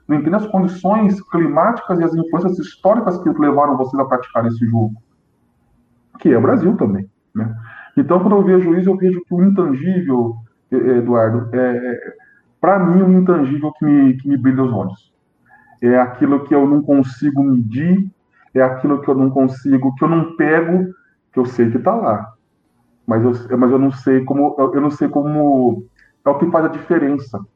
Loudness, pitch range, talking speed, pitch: -15 LUFS, 125-170 Hz, 185 wpm, 140 Hz